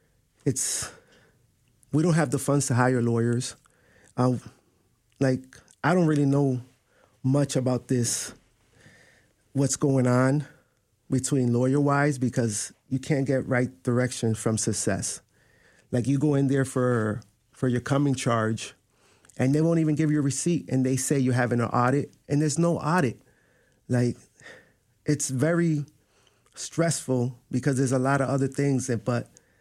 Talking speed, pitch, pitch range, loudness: 150 wpm, 130 Hz, 120-140 Hz, -25 LUFS